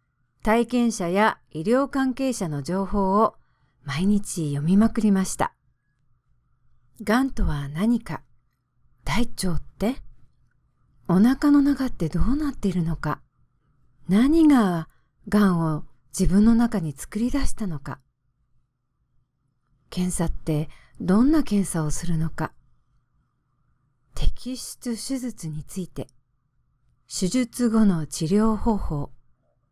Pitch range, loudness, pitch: 135-220 Hz, -23 LUFS, 175 Hz